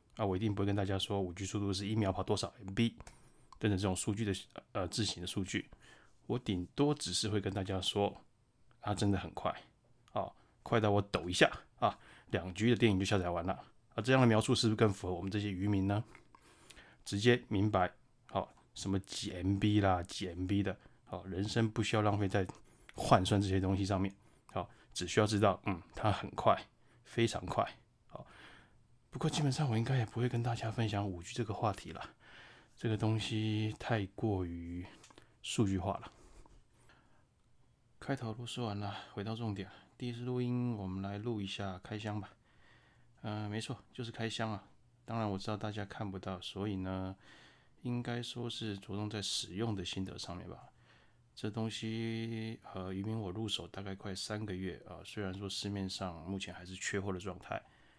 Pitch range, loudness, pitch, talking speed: 95-115 Hz, -36 LUFS, 105 Hz, 275 characters per minute